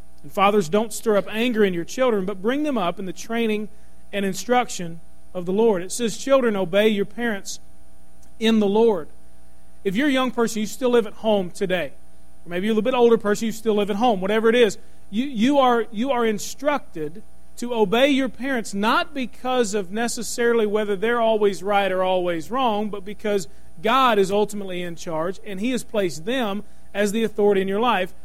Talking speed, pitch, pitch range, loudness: 205 wpm, 210 Hz, 195-235 Hz, -22 LUFS